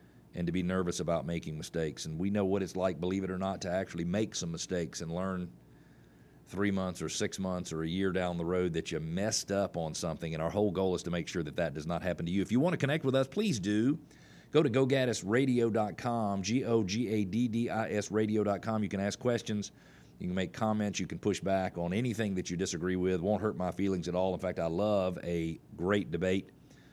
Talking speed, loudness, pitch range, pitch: 225 wpm, -33 LUFS, 90-105 Hz, 95 Hz